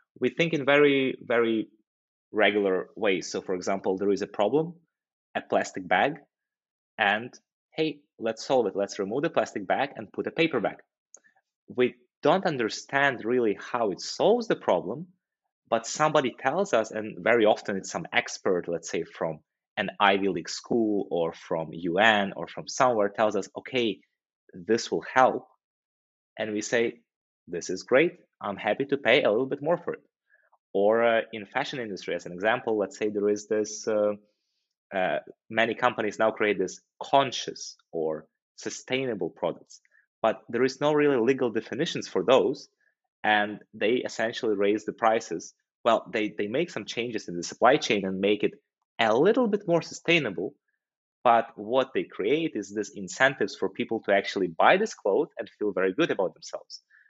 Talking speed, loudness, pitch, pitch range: 170 wpm, -27 LUFS, 115 Hz, 105-145 Hz